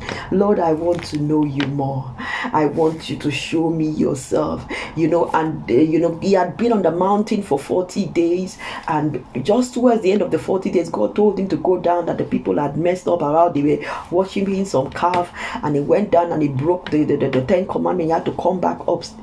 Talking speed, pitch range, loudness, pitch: 235 wpm, 150-185 Hz, -19 LUFS, 170 Hz